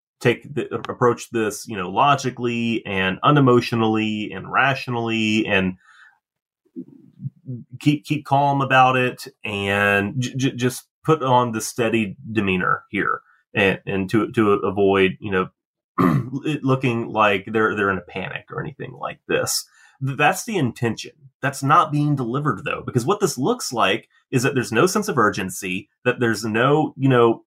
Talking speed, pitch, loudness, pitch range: 155 wpm, 120 Hz, -20 LUFS, 105-135 Hz